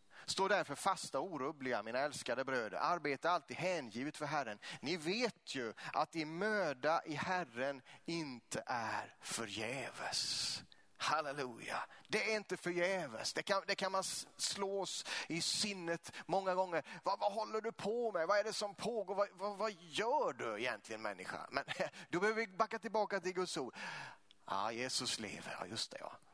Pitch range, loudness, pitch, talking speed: 165-210 Hz, -39 LUFS, 185 Hz, 165 wpm